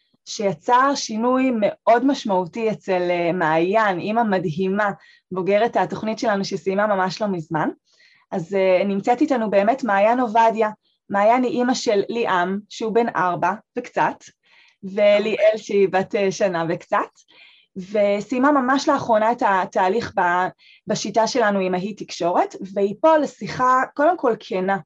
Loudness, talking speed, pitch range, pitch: -20 LUFS, 125 wpm, 190-245 Hz, 210 Hz